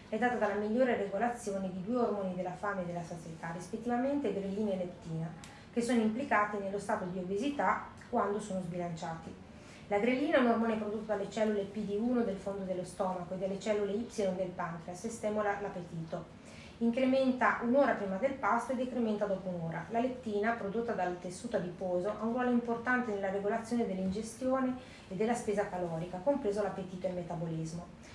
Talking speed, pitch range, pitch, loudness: 170 wpm, 185-230 Hz, 205 Hz, -34 LUFS